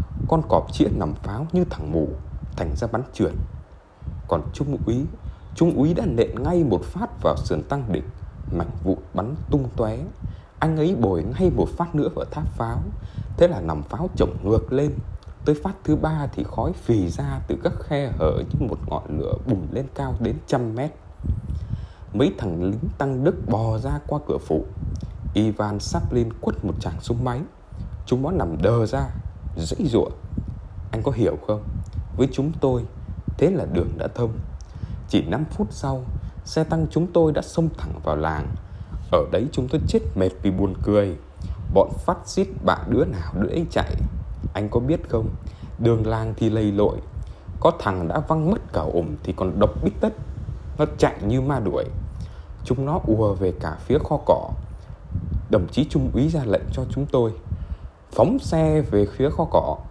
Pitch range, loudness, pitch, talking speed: 90-135 Hz, -24 LUFS, 105 Hz, 185 wpm